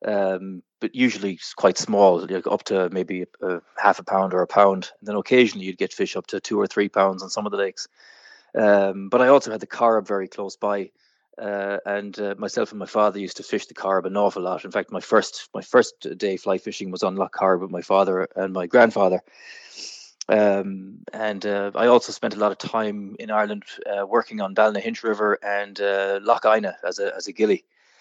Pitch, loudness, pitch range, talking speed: 100 Hz, -22 LUFS, 95-110 Hz, 225 wpm